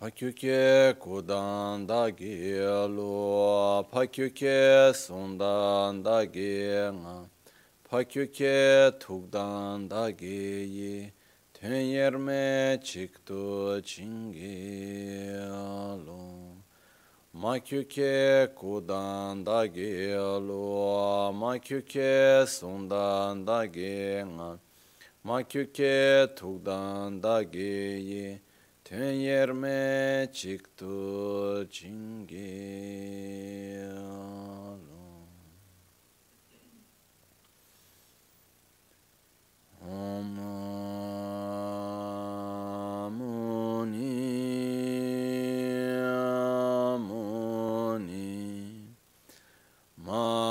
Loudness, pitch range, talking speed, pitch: -29 LUFS, 100-125 Hz, 35 wpm, 100 Hz